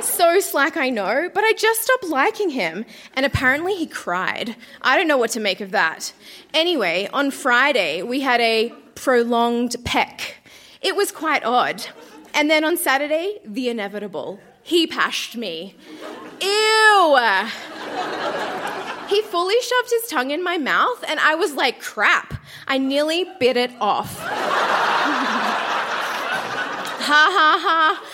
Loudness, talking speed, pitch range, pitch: -19 LUFS, 140 wpm, 245-385 Hz, 305 Hz